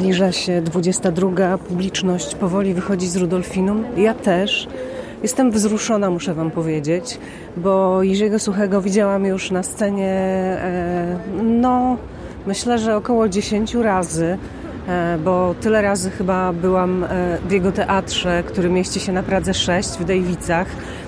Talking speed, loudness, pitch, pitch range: 125 wpm, -19 LUFS, 190 Hz, 180-205 Hz